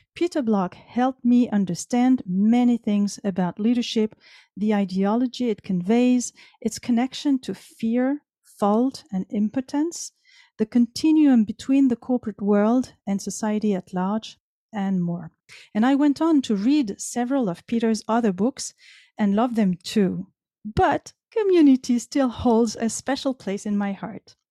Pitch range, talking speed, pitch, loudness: 205-255 Hz, 140 wpm, 230 Hz, -23 LUFS